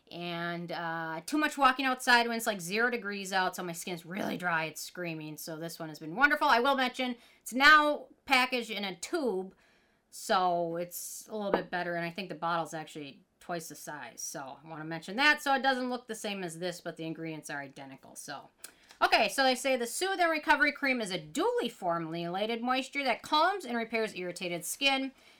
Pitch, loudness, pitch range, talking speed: 205 Hz, -30 LUFS, 170-260 Hz, 210 wpm